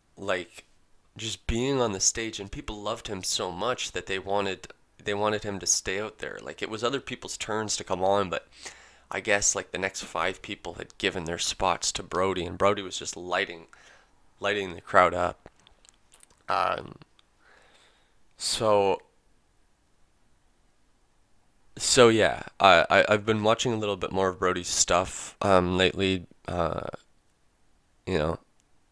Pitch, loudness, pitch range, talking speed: 95 Hz, -26 LUFS, 90-105 Hz, 155 wpm